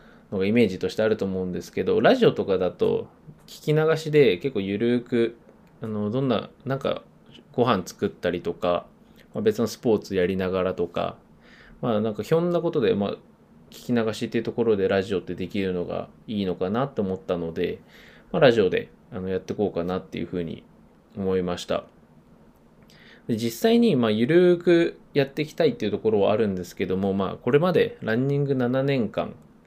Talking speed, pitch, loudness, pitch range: 370 characters per minute, 110 Hz, -24 LUFS, 95-135 Hz